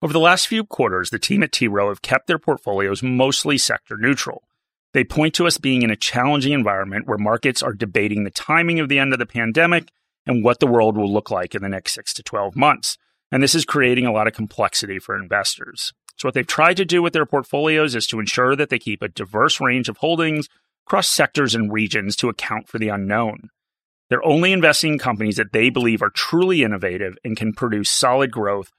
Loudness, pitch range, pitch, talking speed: -19 LUFS, 110-155 Hz, 125 Hz, 225 wpm